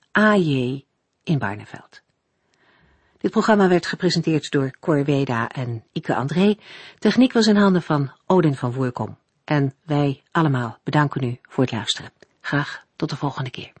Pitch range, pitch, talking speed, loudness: 130-180 Hz, 145 Hz, 150 wpm, -21 LUFS